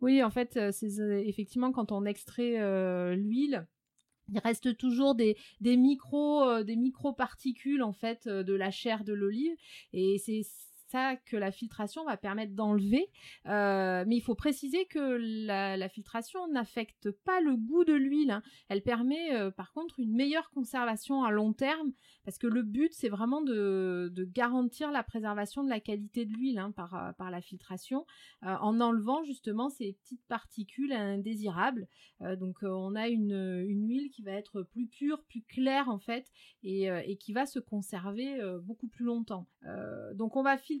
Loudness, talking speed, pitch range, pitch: -33 LUFS, 180 wpm, 200-265 Hz, 230 Hz